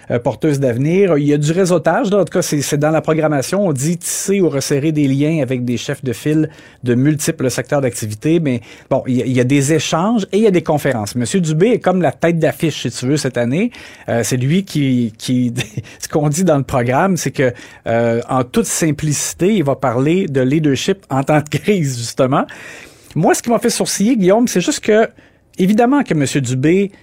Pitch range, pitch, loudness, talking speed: 130-180 Hz, 150 Hz, -16 LUFS, 220 wpm